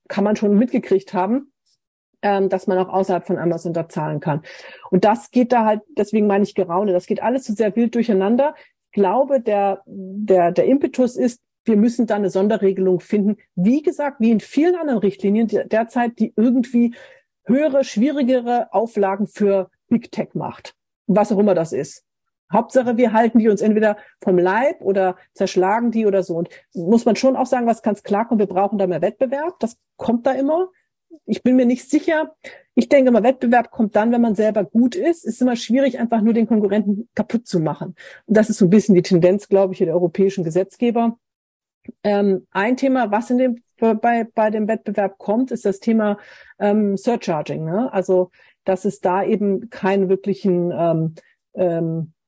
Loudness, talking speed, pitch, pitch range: -19 LUFS, 190 wpm, 215 Hz, 195-240 Hz